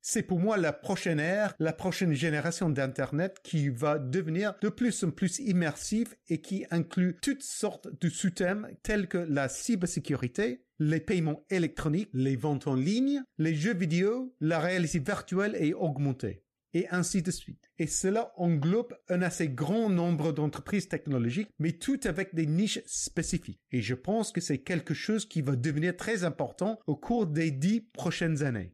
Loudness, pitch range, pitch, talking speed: -31 LUFS, 155-200 Hz, 175 Hz, 170 wpm